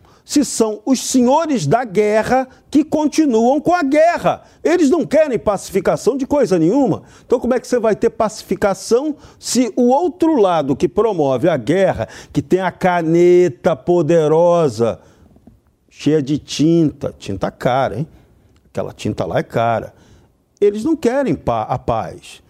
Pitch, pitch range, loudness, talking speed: 215 Hz, 170-270 Hz, -16 LUFS, 145 wpm